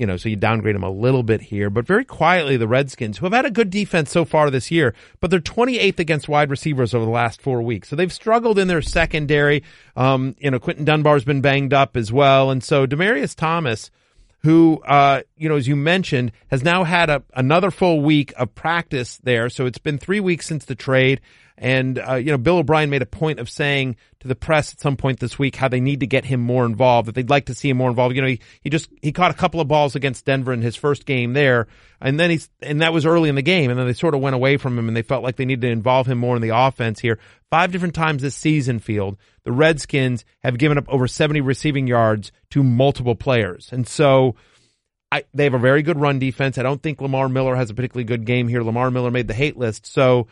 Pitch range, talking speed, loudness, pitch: 125-155 Hz, 255 wpm, -19 LUFS, 135 Hz